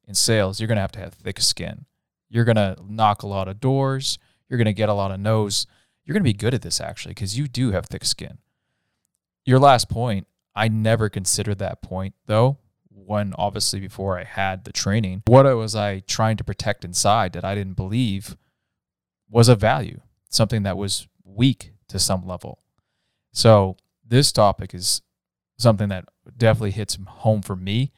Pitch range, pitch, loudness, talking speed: 95-115 Hz, 105 Hz, -21 LUFS, 180 wpm